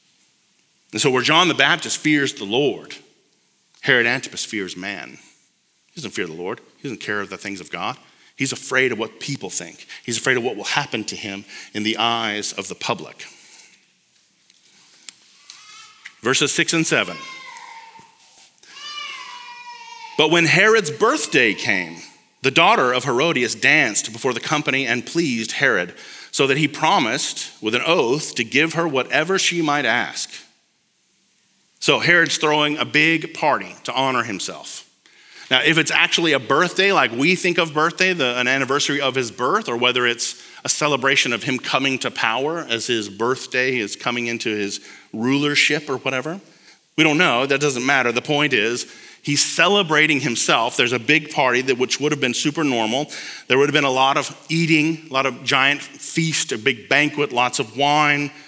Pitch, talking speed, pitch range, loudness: 145 Hz, 170 wpm, 125-165 Hz, -18 LUFS